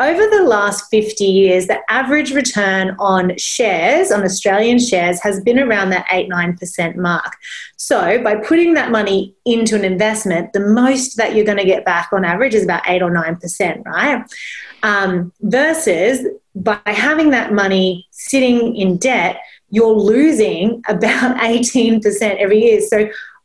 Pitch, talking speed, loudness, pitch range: 215 Hz, 160 wpm, -14 LUFS, 190-240 Hz